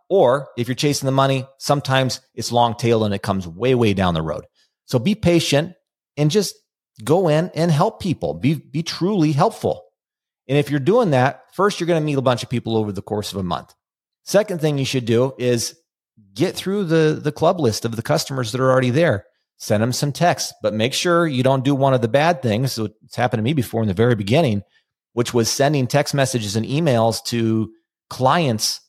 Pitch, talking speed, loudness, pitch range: 130 Hz, 220 wpm, -19 LUFS, 115-155 Hz